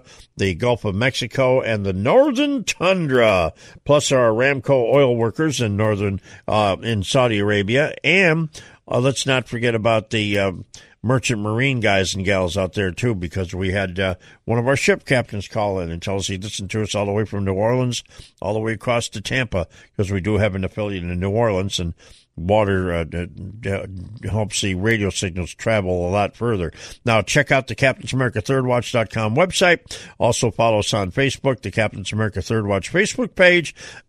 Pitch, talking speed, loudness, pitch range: 110 Hz, 190 wpm, -20 LUFS, 100-125 Hz